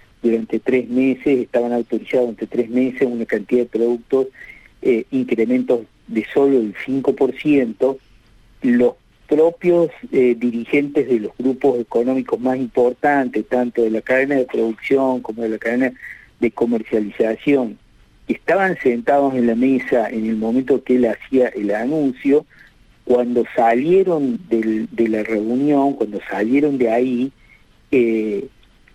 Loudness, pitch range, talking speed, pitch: -18 LUFS, 115-135 Hz, 135 wpm, 125 Hz